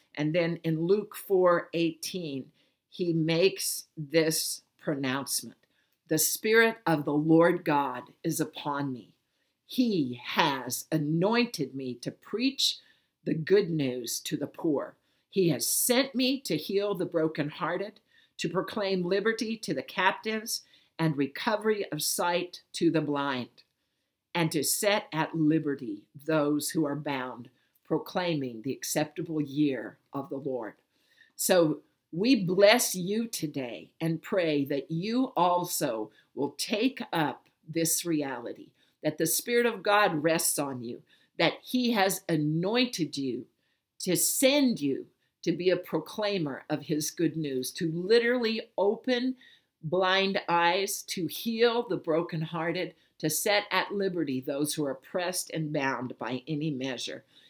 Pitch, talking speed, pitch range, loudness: 165 Hz, 135 wpm, 150-195 Hz, -28 LUFS